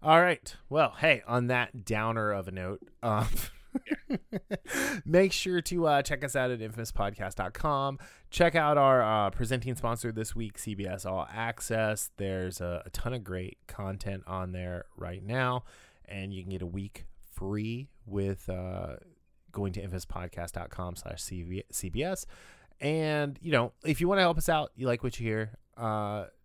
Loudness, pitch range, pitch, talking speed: -31 LUFS, 95-135 Hz, 110 Hz, 165 wpm